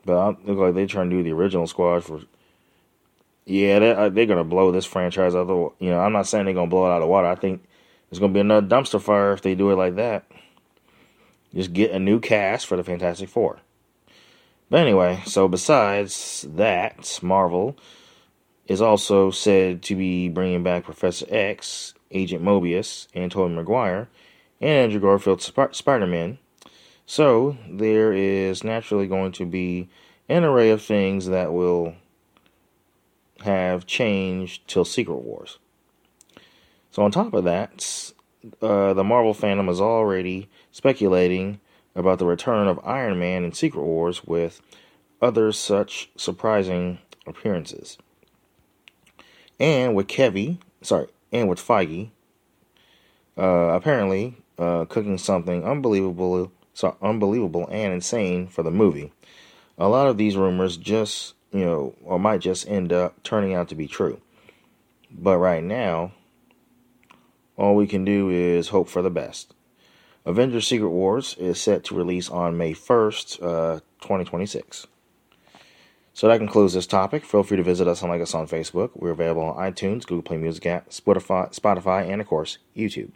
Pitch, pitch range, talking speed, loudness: 95 Hz, 90-100 Hz, 160 wpm, -22 LUFS